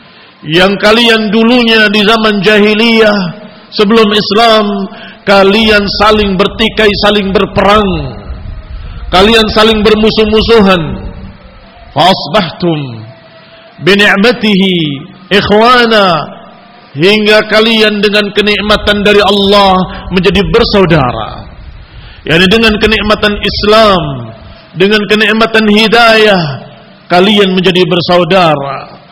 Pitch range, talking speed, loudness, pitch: 185-215 Hz, 80 wpm, -7 LUFS, 205 Hz